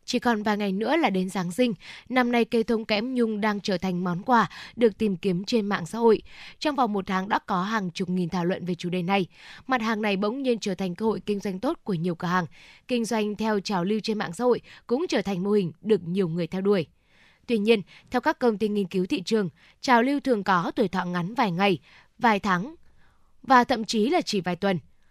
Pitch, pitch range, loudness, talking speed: 210 Hz, 185-235 Hz, -25 LUFS, 250 wpm